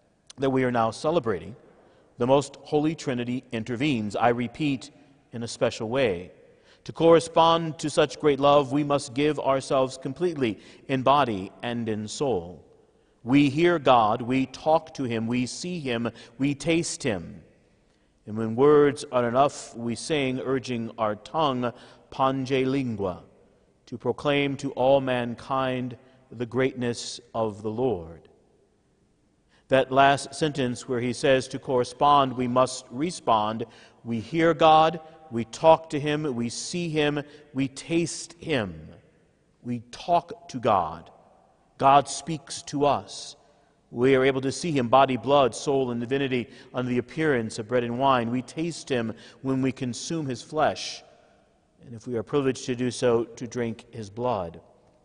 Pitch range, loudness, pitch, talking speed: 120-145 Hz, -25 LUFS, 130 Hz, 150 wpm